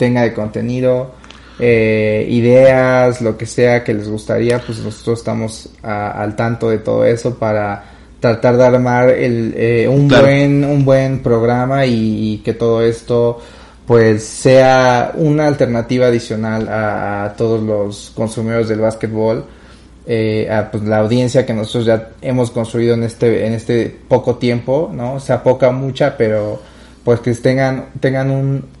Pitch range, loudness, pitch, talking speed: 110-125 Hz, -14 LUFS, 115 Hz, 160 wpm